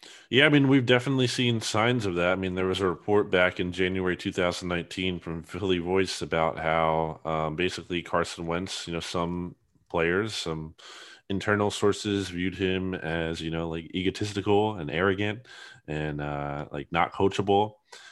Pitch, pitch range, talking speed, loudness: 90 Hz, 80-100 Hz, 160 wpm, -27 LUFS